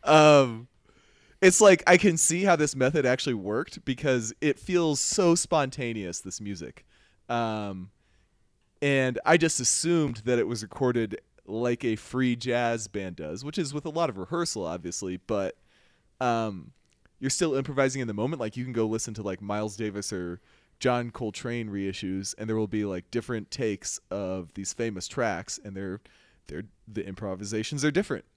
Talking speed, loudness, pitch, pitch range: 170 wpm, -27 LUFS, 115 Hz, 100-140 Hz